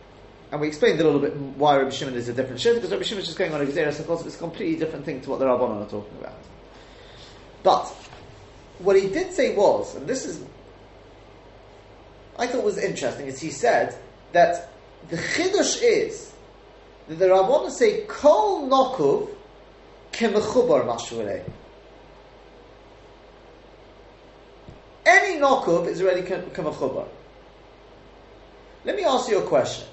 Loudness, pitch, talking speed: -22 LUFS, 185 Hz, 140 wpm